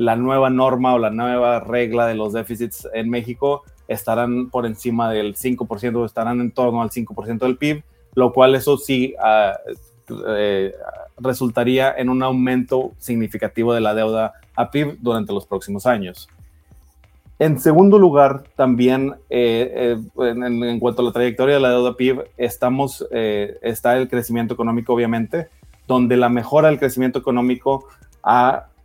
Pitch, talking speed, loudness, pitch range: 120 Hz, 160 wpm, -18 LUFS, 115-130 Hz